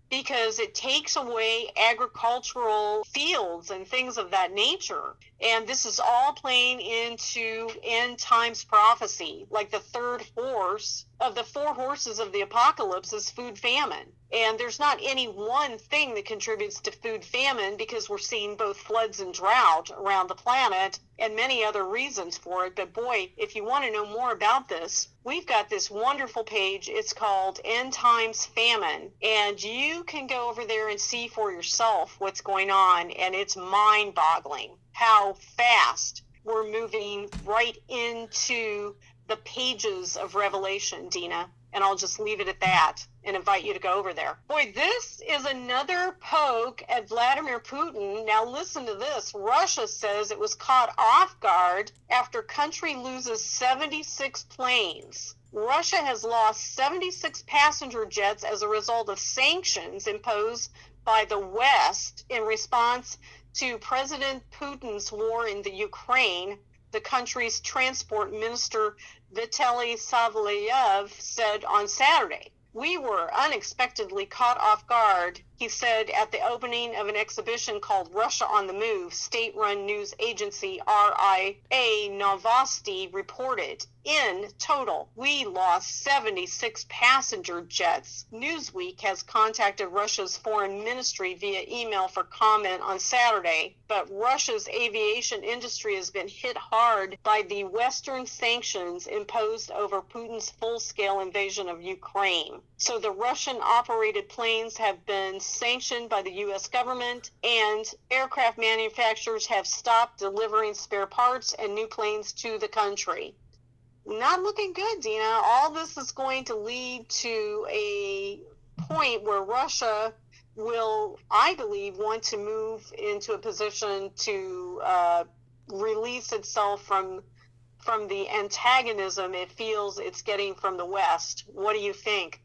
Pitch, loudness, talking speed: 240 Hz, -26 LUFS, 145 wpm